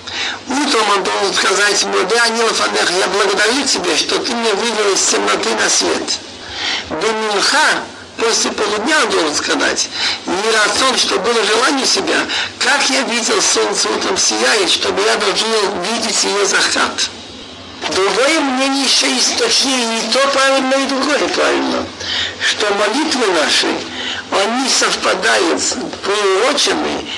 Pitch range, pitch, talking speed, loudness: 215-275 Hz, 255 Hz, 140 wpm, -14 LUFS